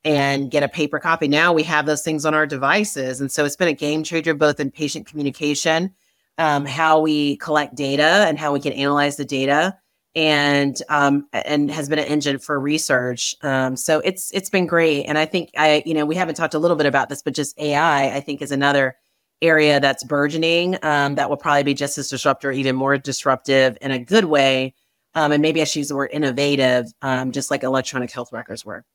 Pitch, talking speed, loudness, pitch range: 145 Hz, 220 wpm, -19 LUFS, 140-155 Hz